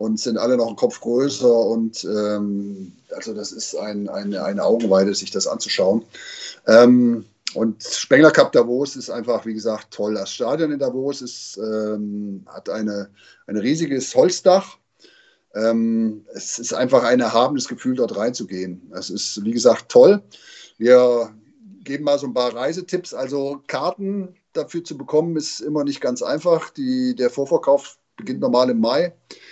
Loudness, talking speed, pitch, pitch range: -19 LUFS, 160 wpm, 125 Hz, 110-150 Hz